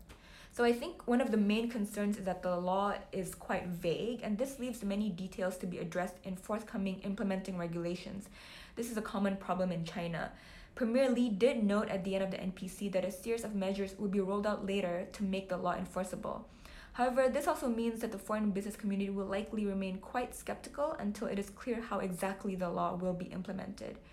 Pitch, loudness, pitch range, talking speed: 200 Hz, -36 LUFS, 190-220 Hz, 210 wpm